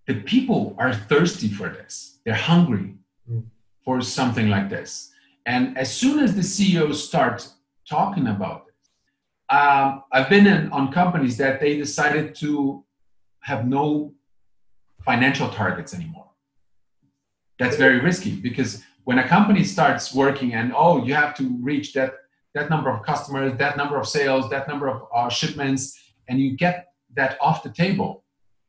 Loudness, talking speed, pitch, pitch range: -21 LUFS, 155 wpm, 135 Hz, 120-150 Hz